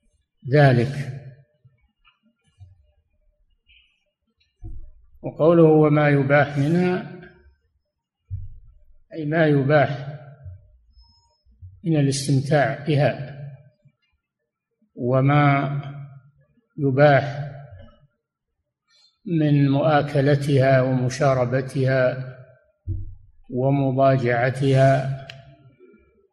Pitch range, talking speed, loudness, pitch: 100-145 Hz, 40 wpm, -19 LUFS, 135 Hz